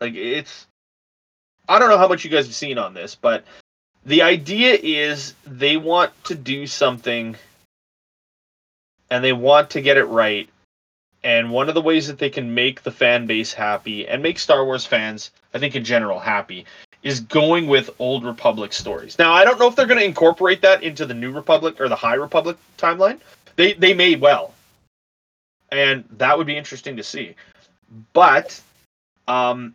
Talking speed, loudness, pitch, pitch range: 180 wpm, -17 LUFS, 140 Hz, 120-165 Hz